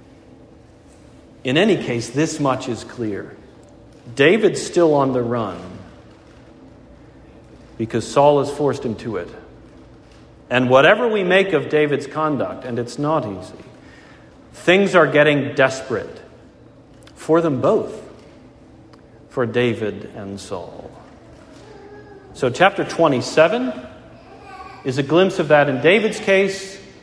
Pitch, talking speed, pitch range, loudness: 135 Hz, 115 wpm, 120-160 Hz, -18 LUFS